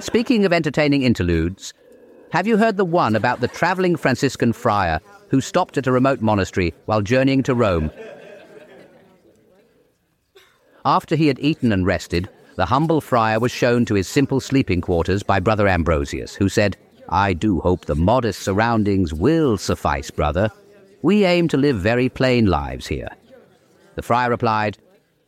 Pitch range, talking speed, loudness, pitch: 95-145 Hz, 155 wpm, -19 LUFS, 120 Hz